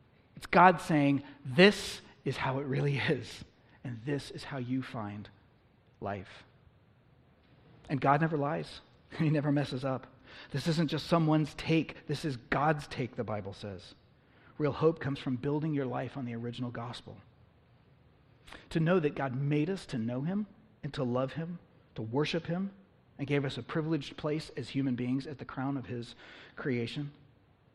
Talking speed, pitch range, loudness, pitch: 170 wpm, 120-150 Hz, -32 LUFS, 135 Hz